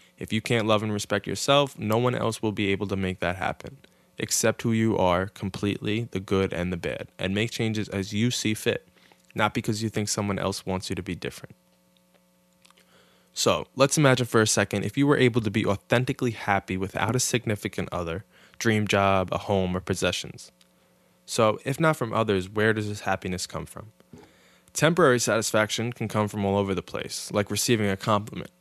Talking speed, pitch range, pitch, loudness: 195 wpm, 95-110 Hz, 105 Hz, -25 LUFS